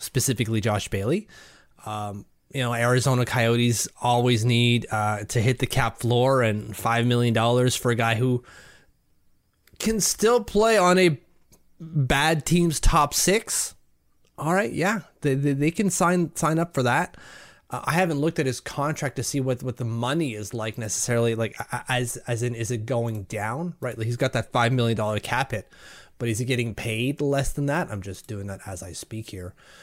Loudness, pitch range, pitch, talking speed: -24 LUFS, 115-145 Hz, 120 Hz, 185 wpm